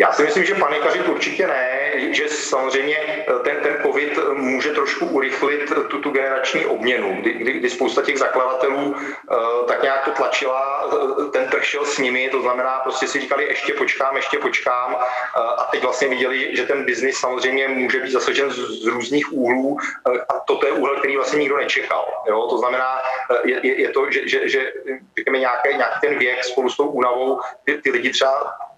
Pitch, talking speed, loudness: 135 Hz, 185 wpm, -19 LUFS